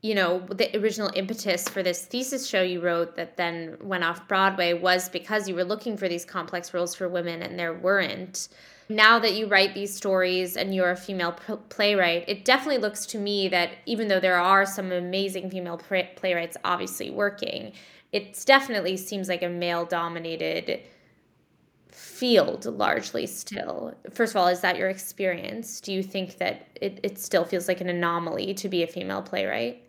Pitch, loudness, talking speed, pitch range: 185 Hz, -26 LUFS, 180 wpm, 175-205 Hz